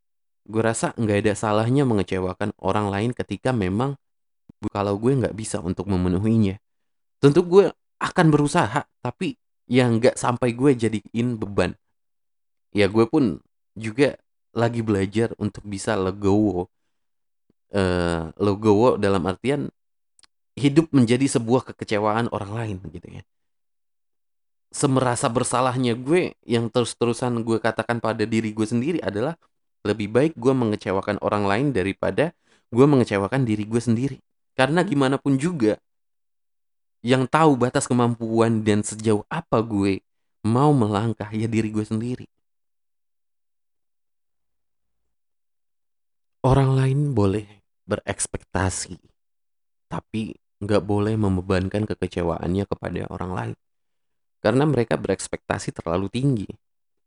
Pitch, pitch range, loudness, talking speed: 110 Hz, 100-125 Hz, -22 LUFS, 115 wpm